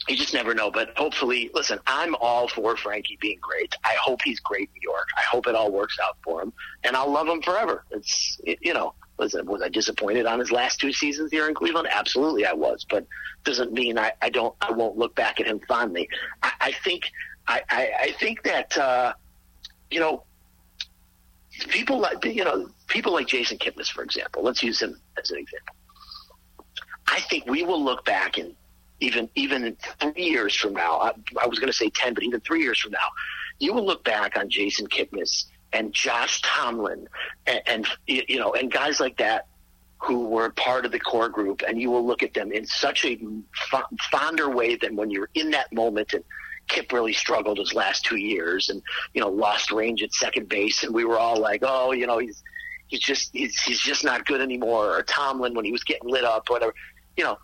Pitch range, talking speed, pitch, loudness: 115-155 Hz, 210 wpm, 120 Hz, -24 LUFS